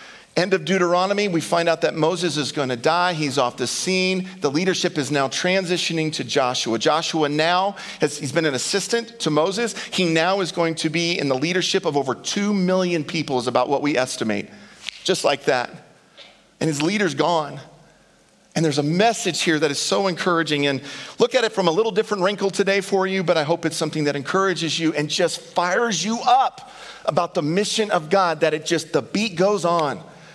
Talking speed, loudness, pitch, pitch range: 205 wpm, -21 LUFS, 170 Hz, 150-190 Hz